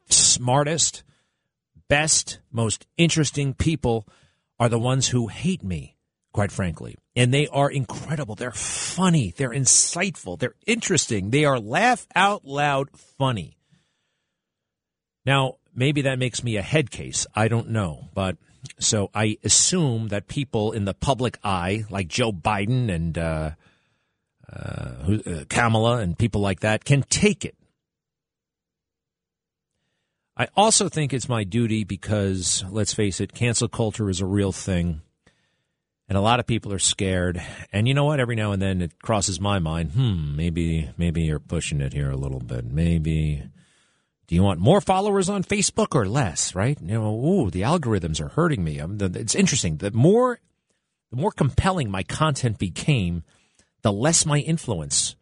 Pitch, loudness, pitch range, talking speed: 115 Hz, -22 LUFS, 95-140 Hz, 155 wpm